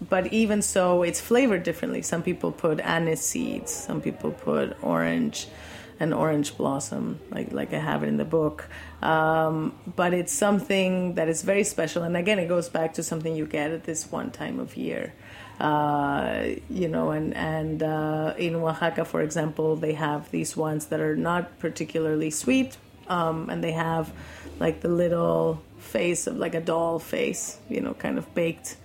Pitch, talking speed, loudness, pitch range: 160 Hz, 180 wpm, -26 LUFS, 150-175 Hz